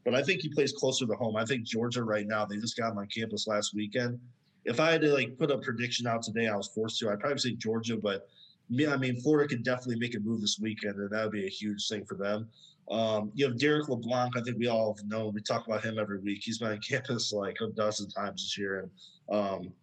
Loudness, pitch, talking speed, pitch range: -31 LUFS, 110 Hz, 265 wpm, 105-125 Hz